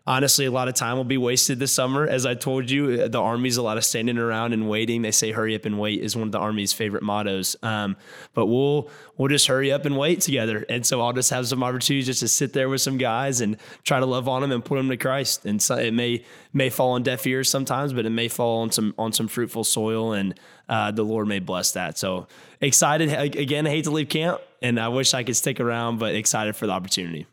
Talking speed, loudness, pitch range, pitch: 260 wpm, -22 LUFS, 110-135 Hz, 125 Hz